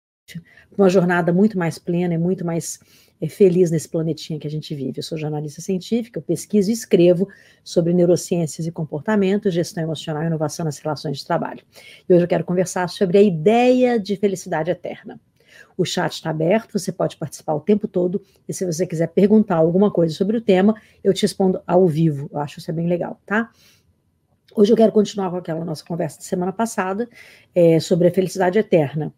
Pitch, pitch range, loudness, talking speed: 180 Hz, 160-200 Hz, -20 LUFS, 195 wpm